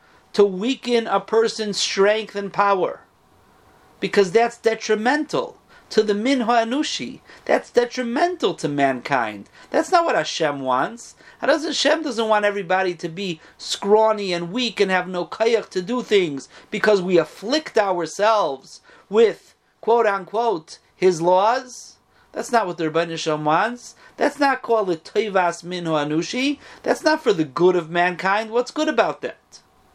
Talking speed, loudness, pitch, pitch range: 145 wpm, -21 LUFS, 210 Hz, 180-245 Hz